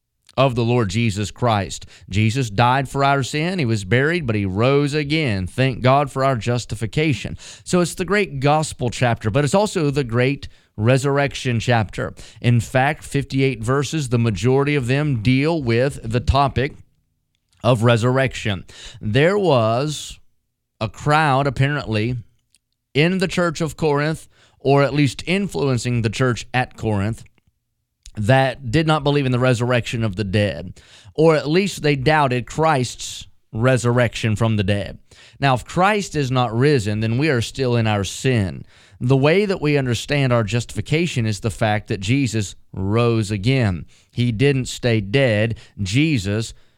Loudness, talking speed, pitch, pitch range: -19 LUFS, 155 wpm, 125 Hz, 110-140 Hz